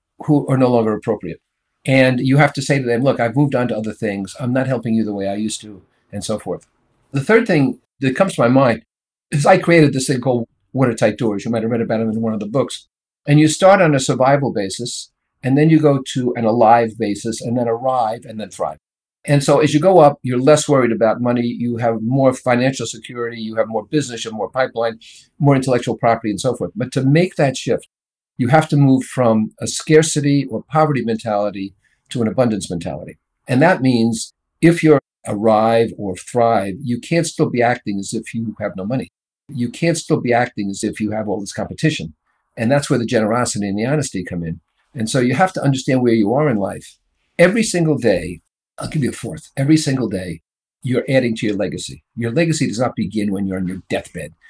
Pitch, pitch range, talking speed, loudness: 120 Hz, 110-140 Hz, 225 wpm, -17 LUFS